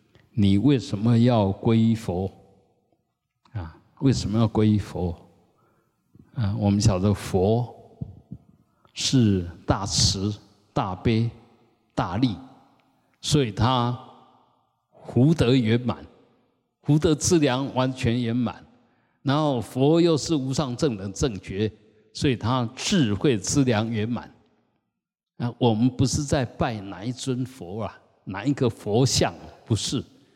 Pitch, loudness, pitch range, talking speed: 115 Hz, -24 LUFS, 105-130 Hz, 160 characters per minute